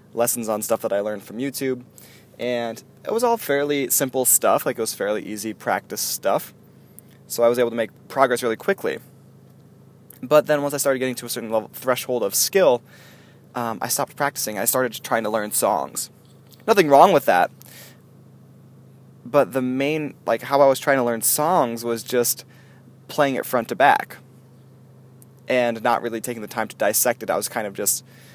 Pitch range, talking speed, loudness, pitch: 115-135 Hz, 190 wpm, -21 LUFS, 125 Hz